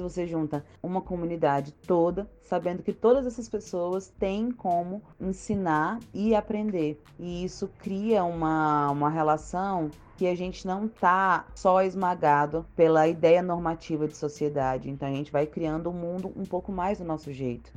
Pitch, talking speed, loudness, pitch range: 175 Hz, 160 wpm, -27 LUFS, 155-190 Hz